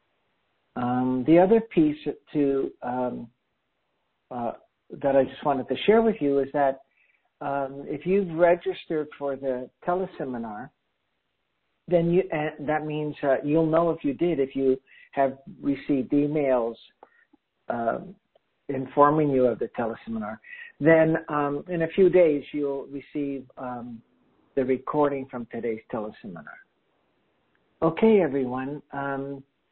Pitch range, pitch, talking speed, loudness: 135-165 Hz, 145 Hz, 130 wpm, -25 LUFS